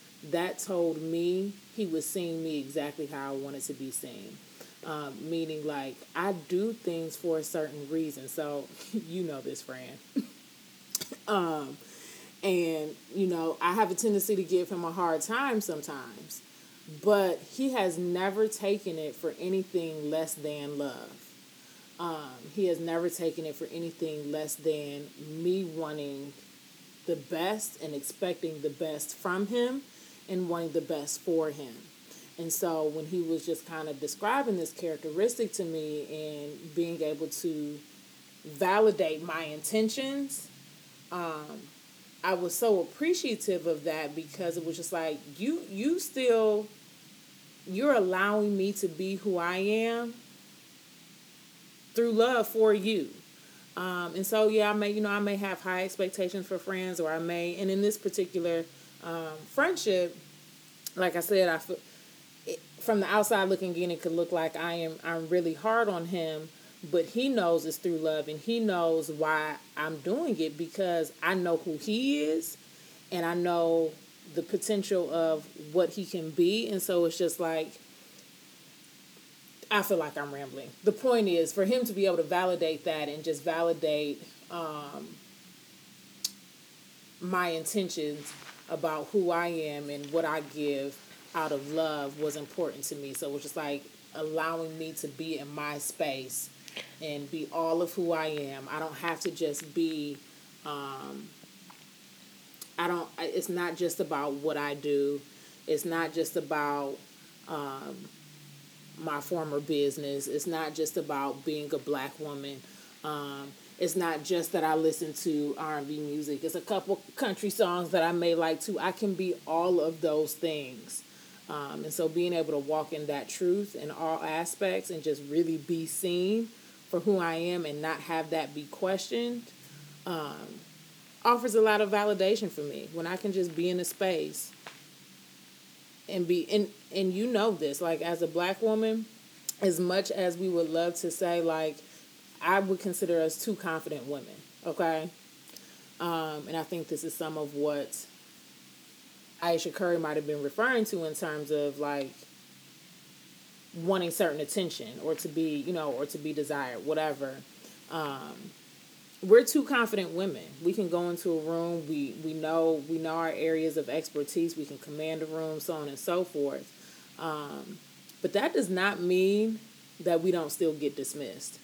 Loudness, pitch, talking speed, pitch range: -31 LUFS, 165 Hz, 165 wpm, 155-185 Hz